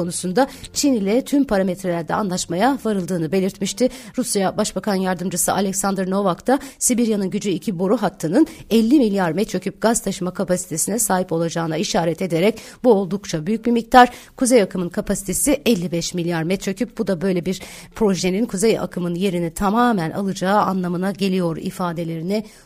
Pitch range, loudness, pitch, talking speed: 180-225 Hz, -20 LUFS, 195 Hz, 140 wpm